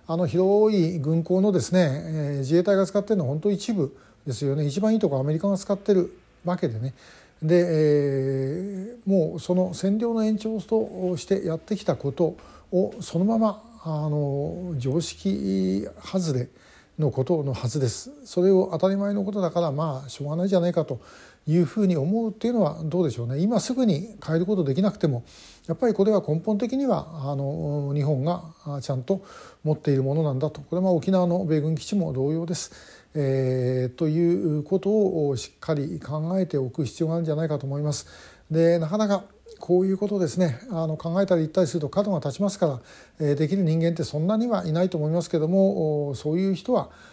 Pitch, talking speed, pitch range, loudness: 170 Hz, 385 characters per minute, 150-195 Hz, -25 LUFS